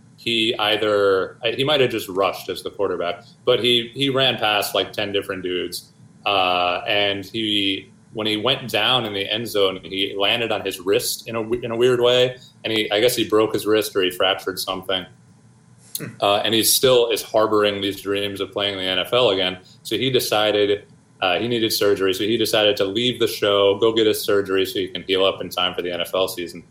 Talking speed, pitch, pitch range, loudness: 215 wpm, 105 Hz, 100-120 Hz, -20 LUFS